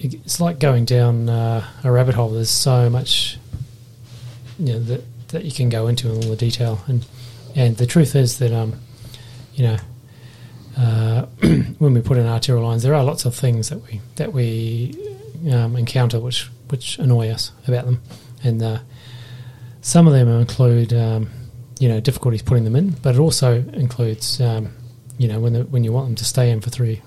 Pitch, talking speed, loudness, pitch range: 120 Hz, 195 wpm, -18 LUFS, 115-125 Hz